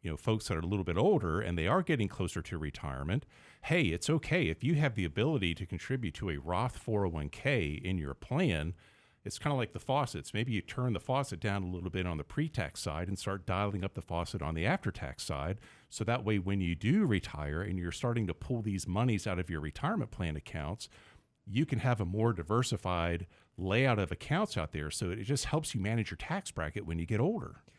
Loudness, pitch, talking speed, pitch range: -34 LUFS, 100 Hz, 230 wpm, 85-120 Hz